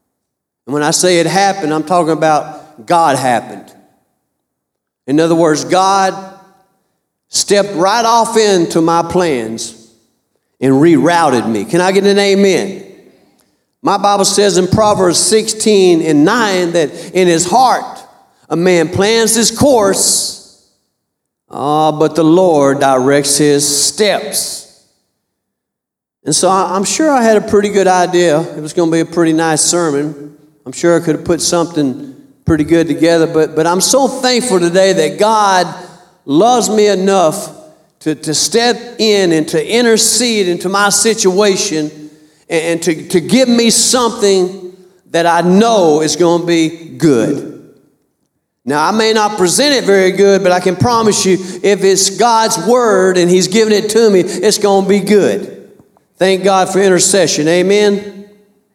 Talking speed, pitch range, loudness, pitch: 155 wpm, 165-205 Hz, -11 LUFS, 185 Hz